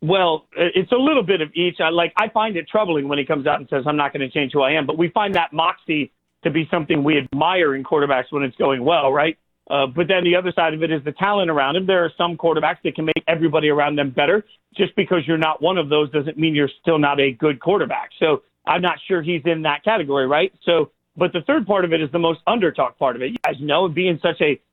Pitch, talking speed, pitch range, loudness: 165 Hz, 270 wpm, 150-180 Hz, -19 LUFS